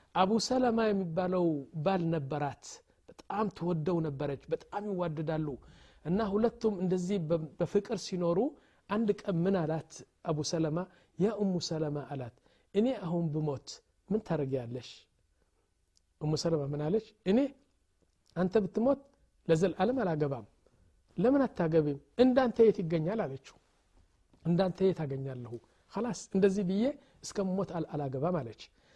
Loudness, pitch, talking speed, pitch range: -32 LUFS, 175 Hz, 105 wpm, 145-205 Hz